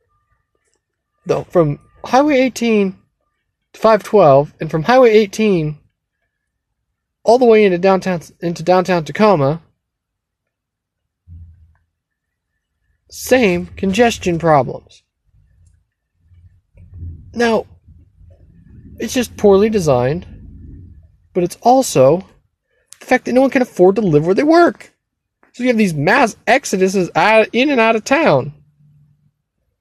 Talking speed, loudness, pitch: 105 wpm, -14 LUFS, 160 Hz